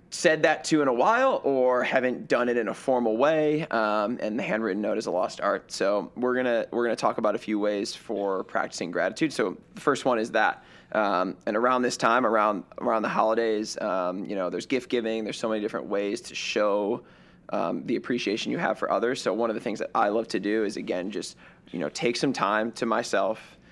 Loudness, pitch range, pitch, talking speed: -26 LUFS, 105-125 Hz, 115 Hz, 235 wpm